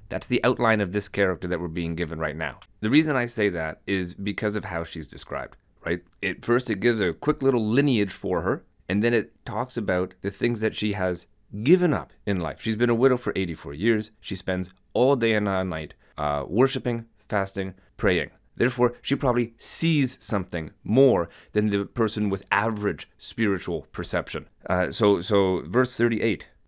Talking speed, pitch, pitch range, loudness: 190 wpm, 105 Hz, 95-120 Hz, -25 LUFS